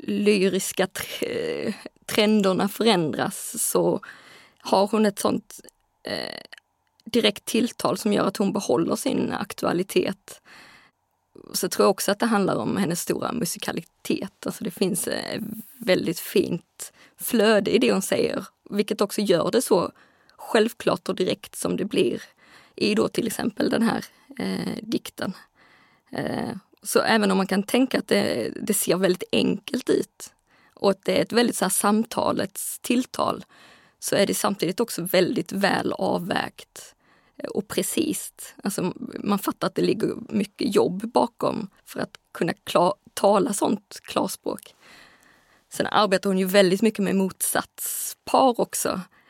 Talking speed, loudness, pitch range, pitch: 145 wpm, -24 LUFS, 195-230 Hz, 210 Hz